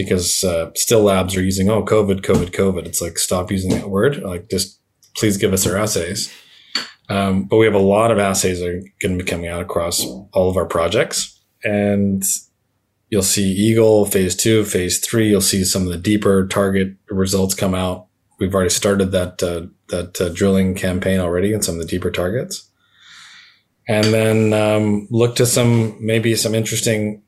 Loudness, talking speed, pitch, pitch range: -17 LUFS, 190 wpm, 100 Hz, 95-105 Hz